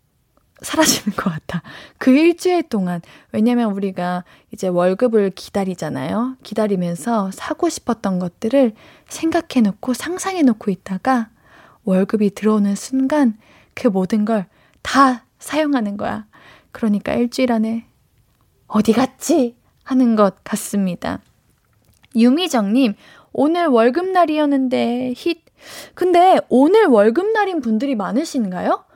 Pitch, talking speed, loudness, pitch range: 235 Hz, 265 characters per minute, -18 LUFS, 205-275 Hz